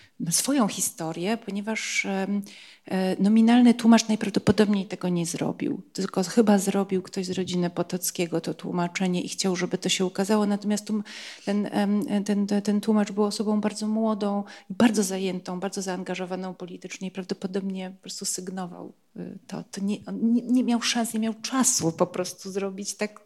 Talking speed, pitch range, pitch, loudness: 145 wpm, 185-215 Hz, 200 Hz, -25 LUFS